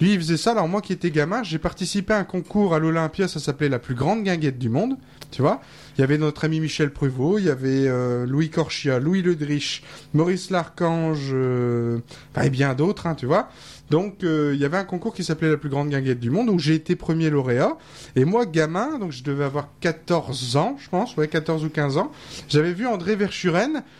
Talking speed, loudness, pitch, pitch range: 225 wpm, -23 LUFS, 160 Hz, 140-180 Hz